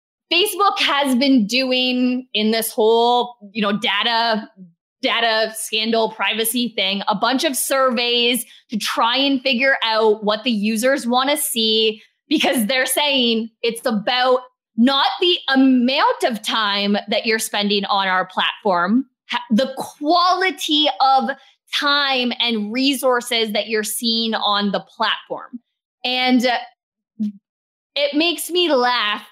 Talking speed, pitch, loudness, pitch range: 125 wpm, 240 Hz, -18 LUFS, 220-270 Hz